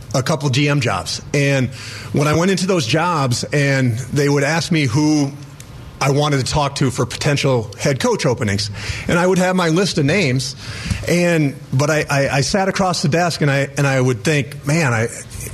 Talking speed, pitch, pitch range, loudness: 205 wpm, 140 Hz, 125-155 Hz, -17 LUFS